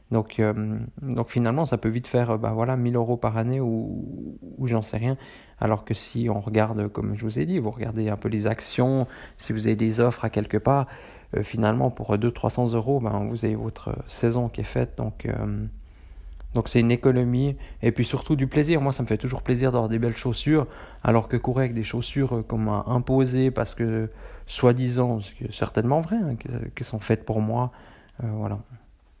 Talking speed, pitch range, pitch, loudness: 210 wpm, 110-125 Hz, 115 Hz, -25 LUFS